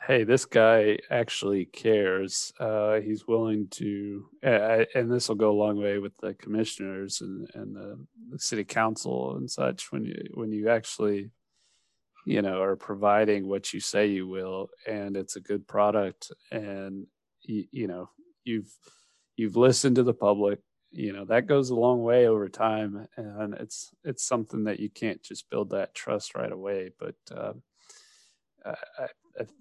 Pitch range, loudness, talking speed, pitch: 100-110 Hz, -27 LUFS, 170 wpm, 105 Hz